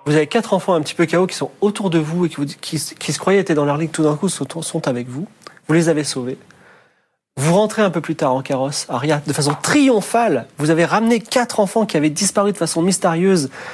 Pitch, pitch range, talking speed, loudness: 165 Hz, 150-195 Hz, 250 wpm, -18 LUFS